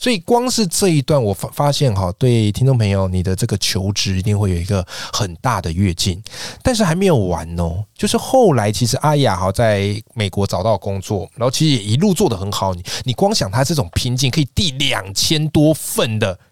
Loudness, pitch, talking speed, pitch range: -17 LUFS, 115 Hz, 310 characters per minute, 100-150 Hz